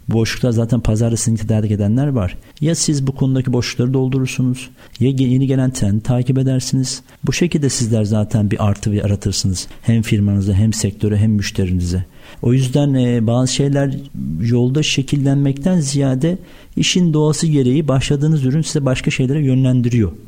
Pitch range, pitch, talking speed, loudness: 110-140 Hz, 130 Hz, 140 wpm, -16 LUFS